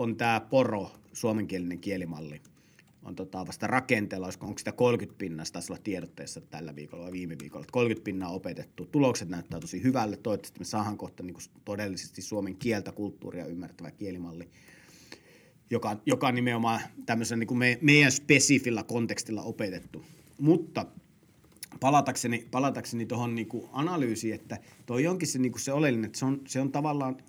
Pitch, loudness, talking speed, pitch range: 115 Hz, -29 LUFS, 145 wpm, 95-125 Hz